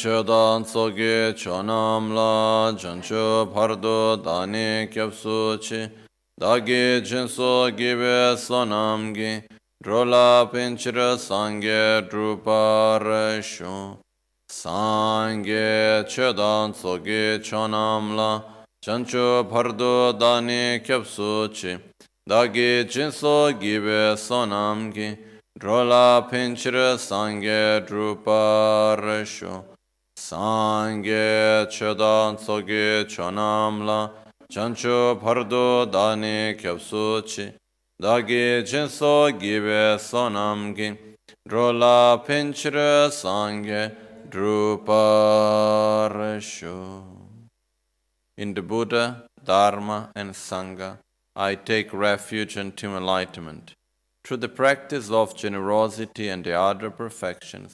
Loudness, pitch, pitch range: -22 LUFS, 110 Hz, 105-120 Hz